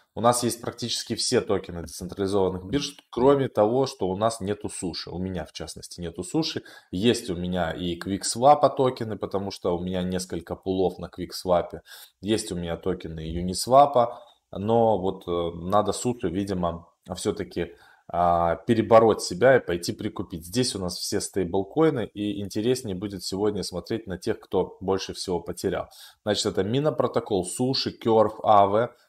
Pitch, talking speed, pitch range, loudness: 100 Hz, 155 wpm, 90-115 Hz, -25 LUFS